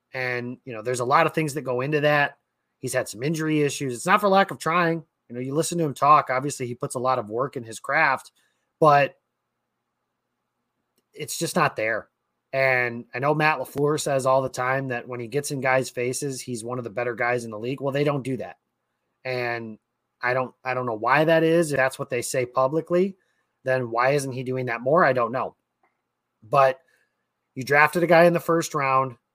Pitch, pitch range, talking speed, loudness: 130 Hz, 125-150 Hz, 225 wpm, -23 LUFS